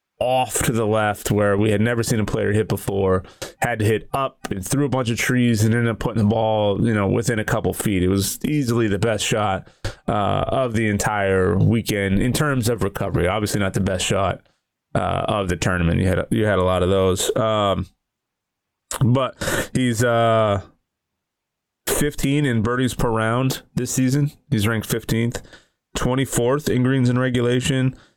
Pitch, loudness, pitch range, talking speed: 110 Hz, -20 LUFS, 100-125 Hz, 185 wpm